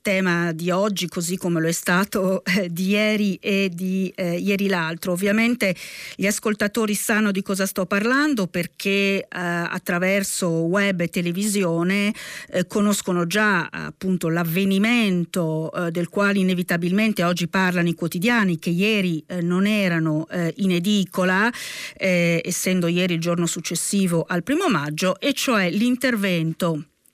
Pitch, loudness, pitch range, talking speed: 185 Hz, -21 LUFS, 175-200 Hz, 140 wpm